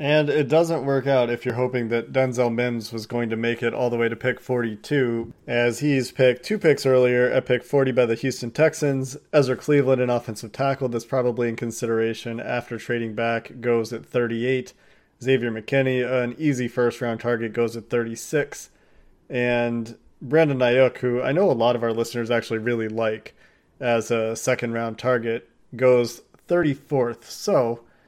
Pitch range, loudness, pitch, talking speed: 115-130 Hz, -23 LUFS, 120 Hz, 175 wpm